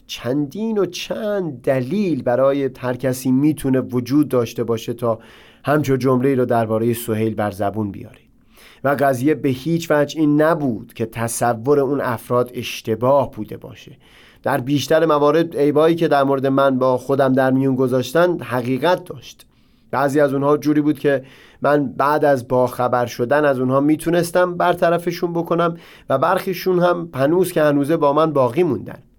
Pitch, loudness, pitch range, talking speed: 140 Hz, -18 LUFS, 125-155 Hz, 155 wpm